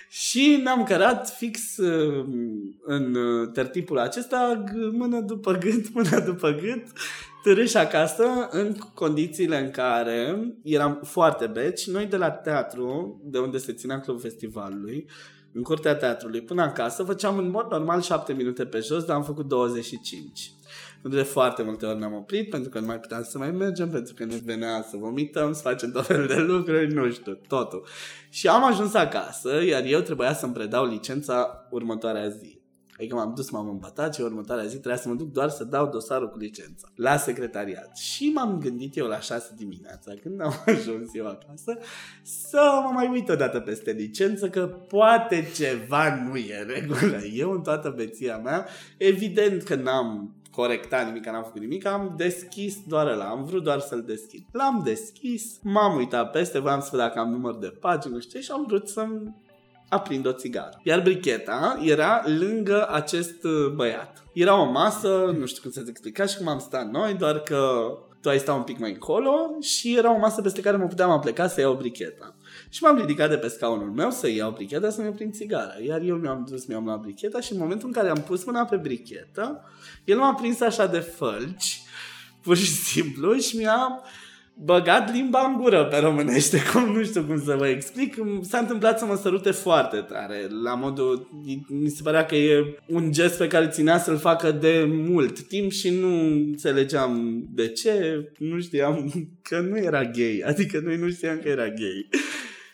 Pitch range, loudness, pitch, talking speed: 125-200 Hz, -25 LUFS, 155 Hz, 185 wpm